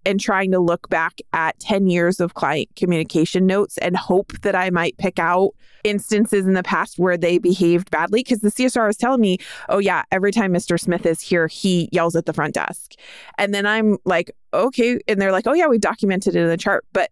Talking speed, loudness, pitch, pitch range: 225 wpm, -19 LUFS, 190 Hz, 175-205 Hz